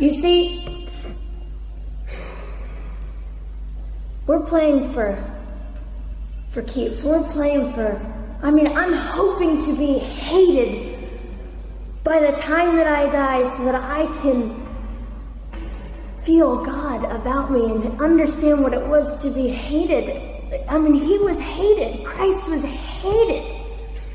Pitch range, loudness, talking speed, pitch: 230-315 Hz, -19 LUFS, 115 wpm, 285 Hz